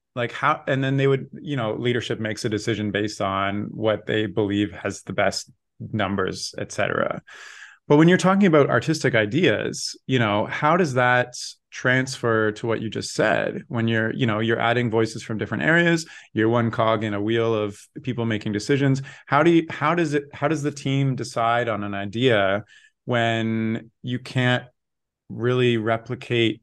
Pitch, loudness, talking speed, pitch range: 115 Hz, -22 LUFS, 180 wpm, 110-135 Hz